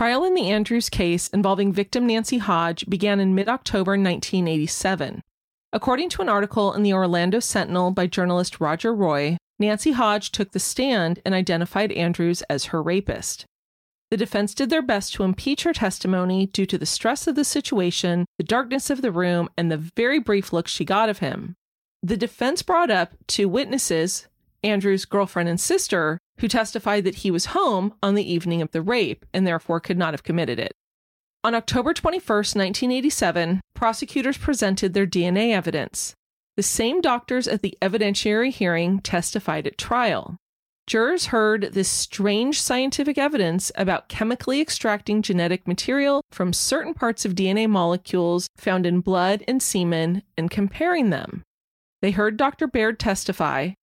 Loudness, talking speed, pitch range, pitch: -22 LUFS, 165 wpm, 180-235 Hz, 200 Hz